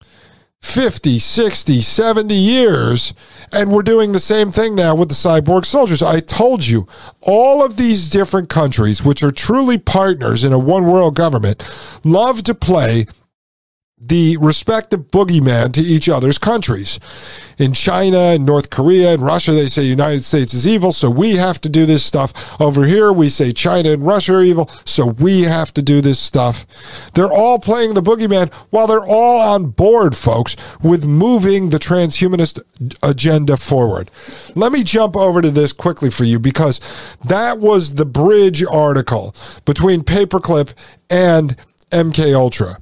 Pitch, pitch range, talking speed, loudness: 160 Hz, 135-195 Hz, 160 wpm, -13 LUFS